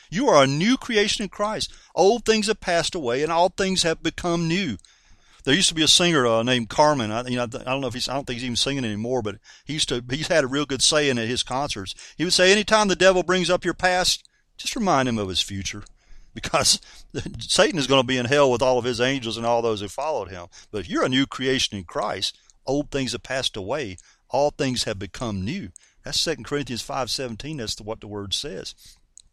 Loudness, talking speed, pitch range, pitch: -22 LUFS, 245 wpm, 120-170 Hz, 135 Hz